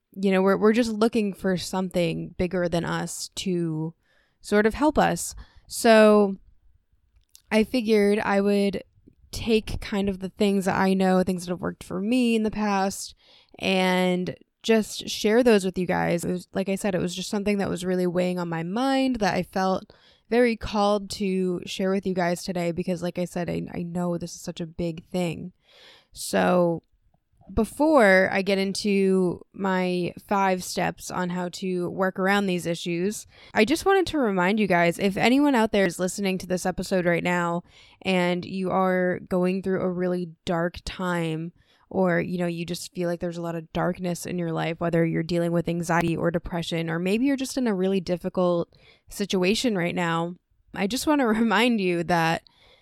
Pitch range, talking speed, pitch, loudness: 175-200 Hz, 190 wpm, 185 Hz, -24 LUFS